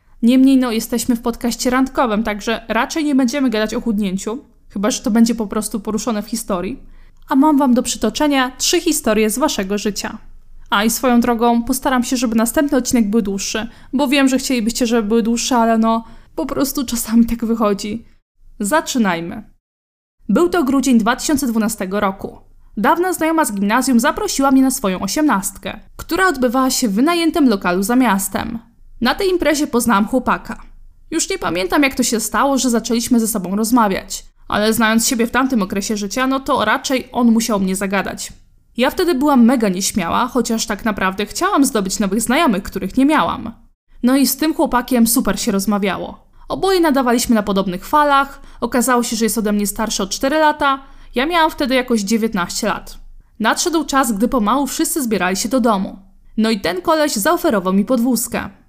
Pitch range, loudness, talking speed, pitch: 220-270 Hz, -16 LUFS, 175 wpm, 240 Hz